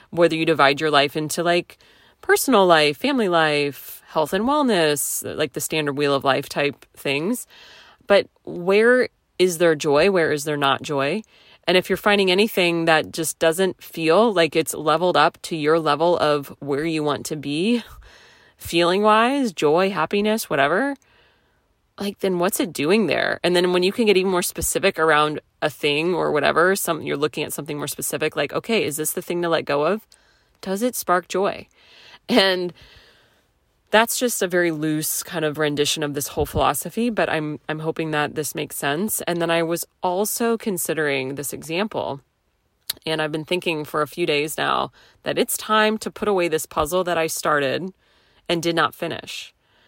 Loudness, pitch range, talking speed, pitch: -21 LUFS, 150-190 Hz, 185 wpm, 165 Hz